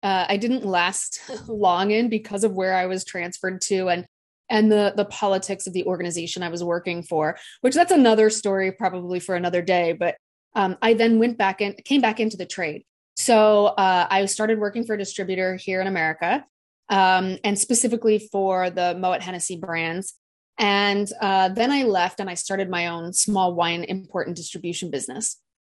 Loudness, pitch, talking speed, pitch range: -22 LUFS, 190 Hz, 185 wpm, 180-210 Hz